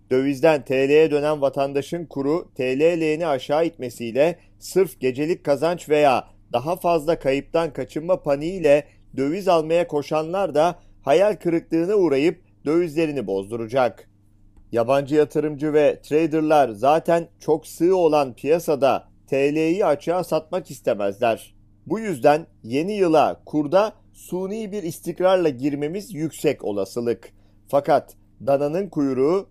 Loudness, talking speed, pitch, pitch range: -21 LUFS, 110 wpm, 150 Hz, 135-170 Hz